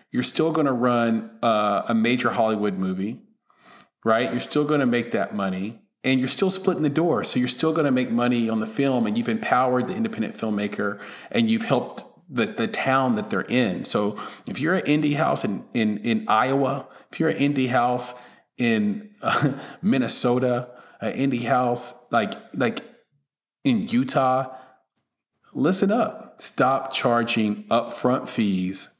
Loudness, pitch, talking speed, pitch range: -21 LUFS, 130 Hz, 160 wpm, 115-150 Hz